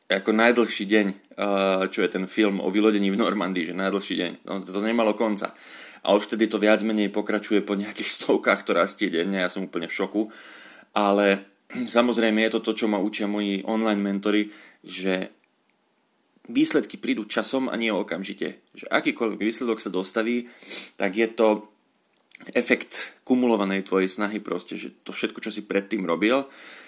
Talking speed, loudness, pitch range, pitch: 165 wpm, -24 LUFS, 100-115 Hz, 105 Hz